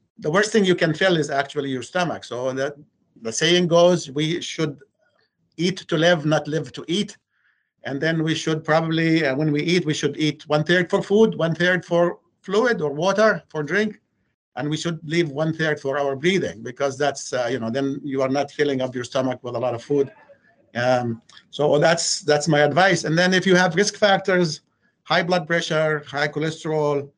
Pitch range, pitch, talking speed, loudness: 145-180 Hz, 155 Hz, 205 wpm, -21 LUFS